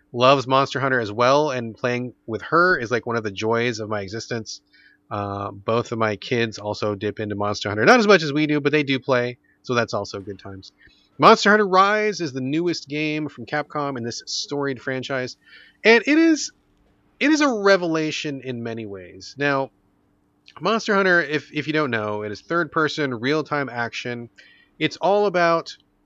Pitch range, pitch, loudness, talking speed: 110-155 Hz, 130 Hz, -21 LUFS, 190 wpm